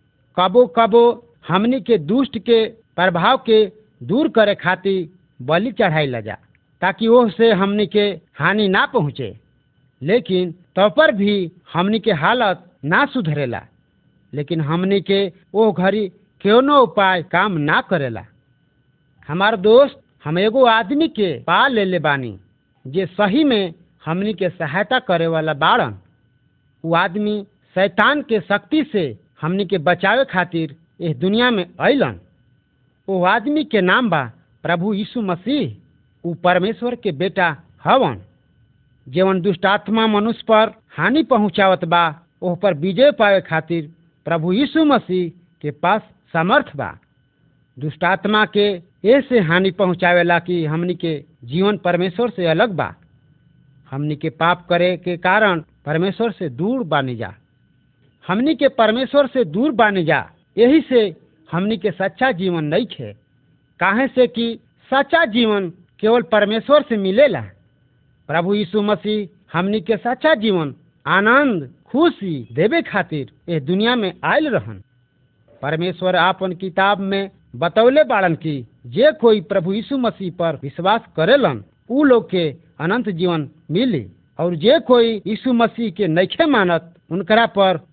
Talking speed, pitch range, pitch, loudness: 140 wpm, 160-220 Hz, 185 Hz, -17 LUFS